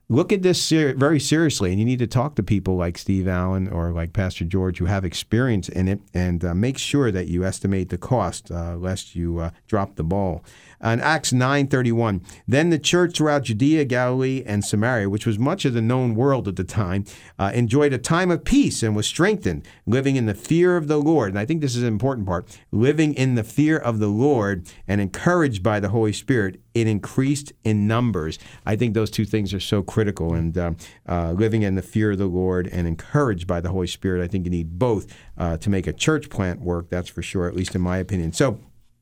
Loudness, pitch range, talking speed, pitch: -22 LUFS, 90-130 Hz, 225 wpm, 105 Hz